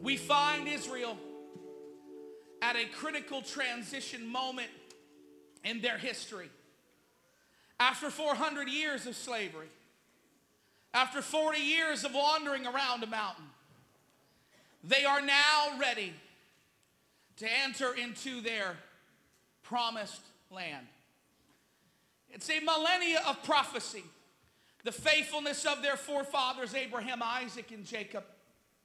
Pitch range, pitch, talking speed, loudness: 220-285 Hz, 255 Hz, 100 wpm, -32 LUFS